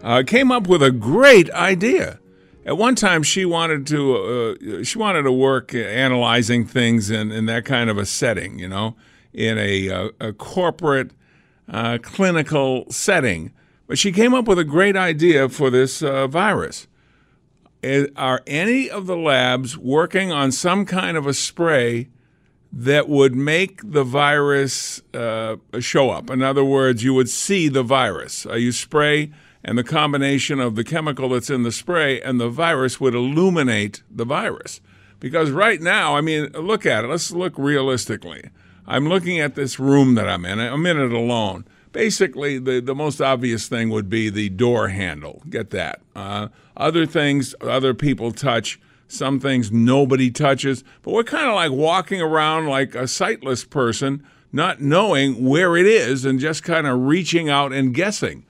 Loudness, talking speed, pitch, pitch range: -19 LUFS, 170 wpm, 135 Hz, 120-155 Hz